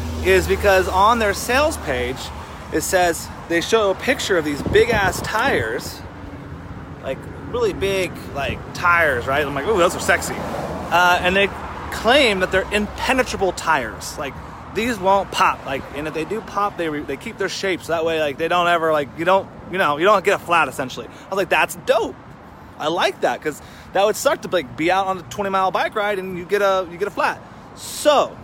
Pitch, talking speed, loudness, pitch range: 190 Hz, 215 wpm, -19 LUFS, 170-205 Hz